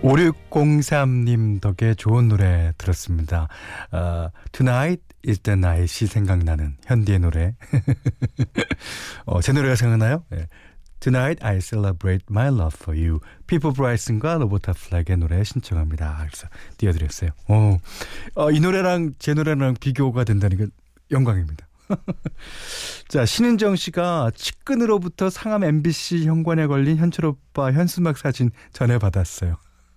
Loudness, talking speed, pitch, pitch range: -21 LUFS, 335 characters per minute, 115 Hz, 90-150 Hz